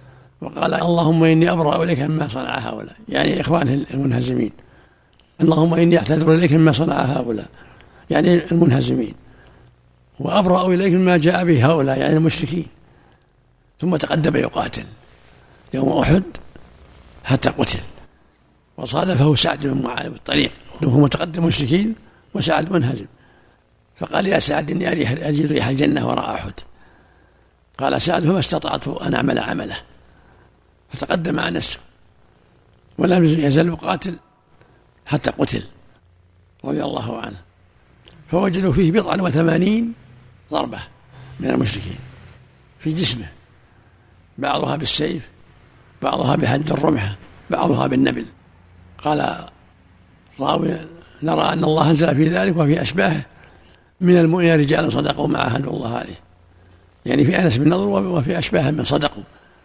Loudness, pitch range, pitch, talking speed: -18 LUFS, 100-165 Hz, 145 Hz, 115 wpm